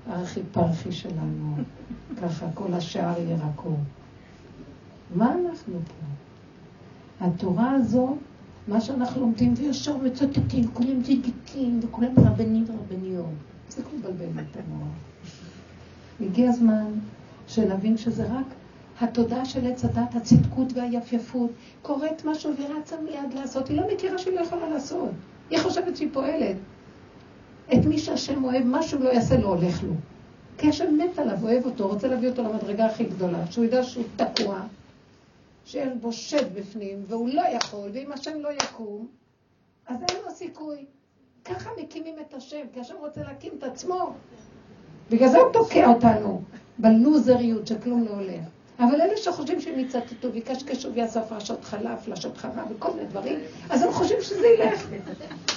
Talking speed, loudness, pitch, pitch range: 145 wpm, -25 LUFS, 240 Hz, 210-290 Hz